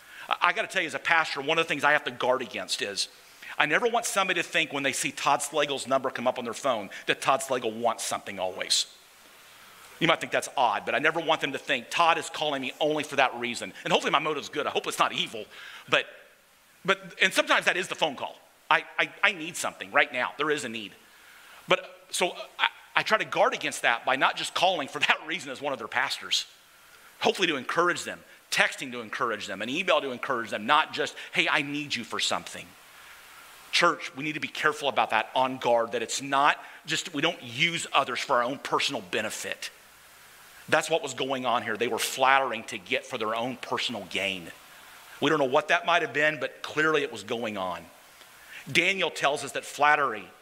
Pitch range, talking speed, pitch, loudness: 135-175 Hz, 230 wpm, 155 Hz, -27 LUFS